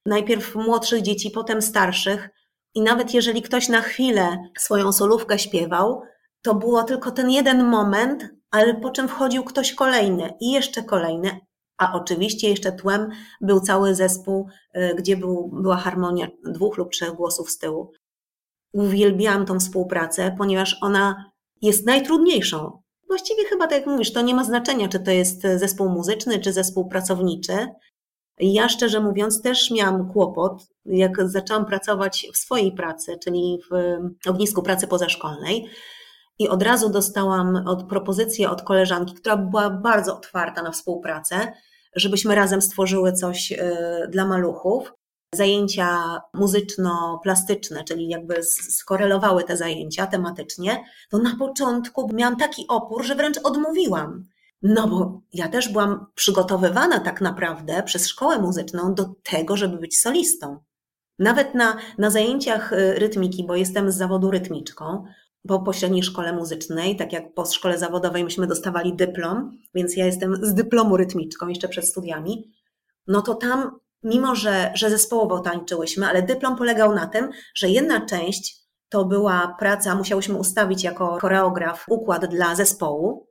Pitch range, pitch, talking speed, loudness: 180-220 Hz, 195 Hz, 145 wpm, -21 LUFS